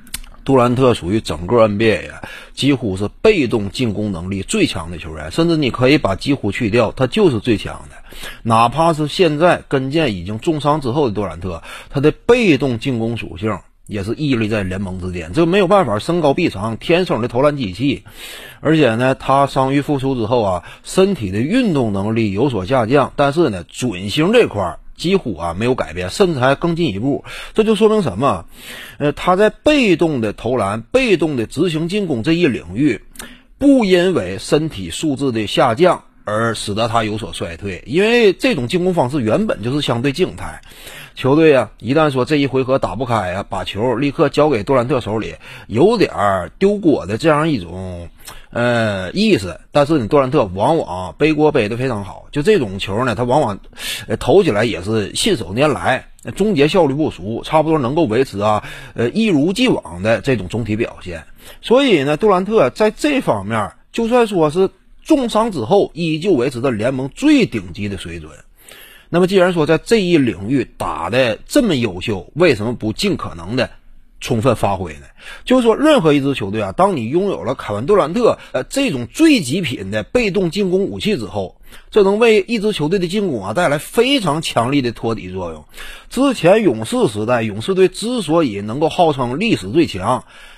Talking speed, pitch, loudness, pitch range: 280 characters per minute, 135 Hz, -16 LUFS, 110-175 Hz